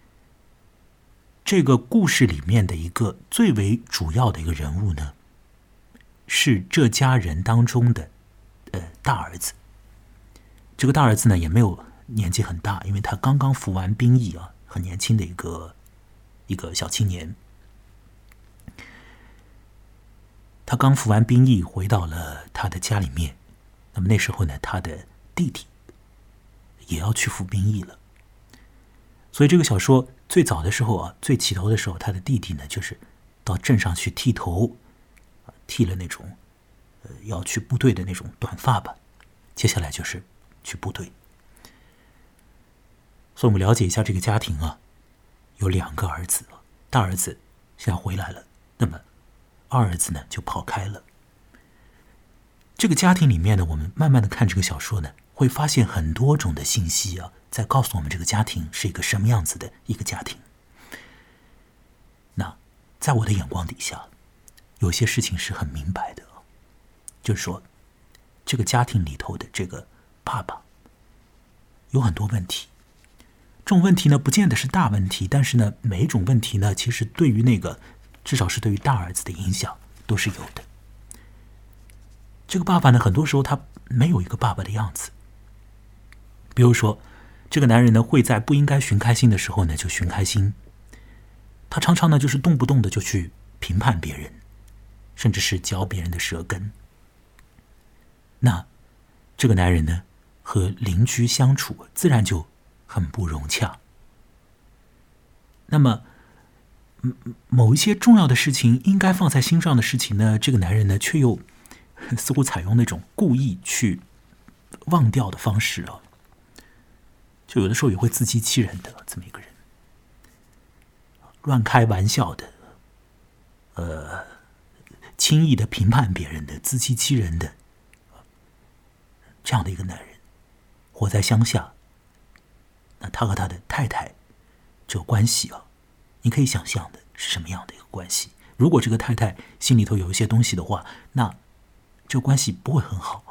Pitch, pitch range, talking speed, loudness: 105 Hz, 95-120 Hz, 225 characters per minute, -22 LUFS